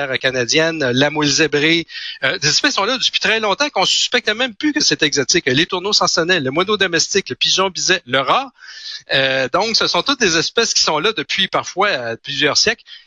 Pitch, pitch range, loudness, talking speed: 165 Hz, 140-195 Hz, -15 LUFS, 210 wpm